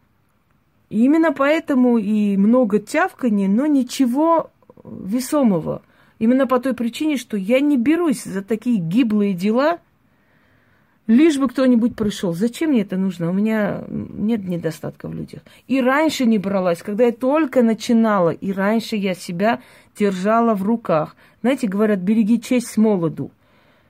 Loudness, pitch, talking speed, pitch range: -19 LUFS, 230 Hz, 140 wpm, 205-260 Hz